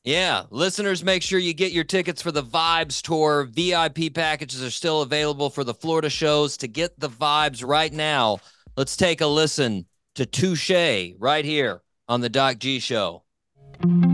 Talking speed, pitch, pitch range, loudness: 170 wpm, 150 Hz, 135-165 Hz, -22 LUFS